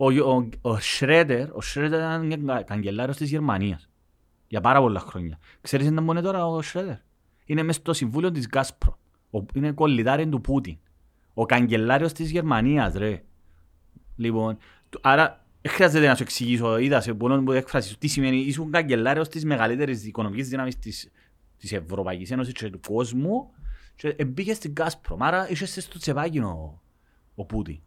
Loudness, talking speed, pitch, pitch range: -24 LUFS, 145 wpm, 130 Hz, 100-150 Hz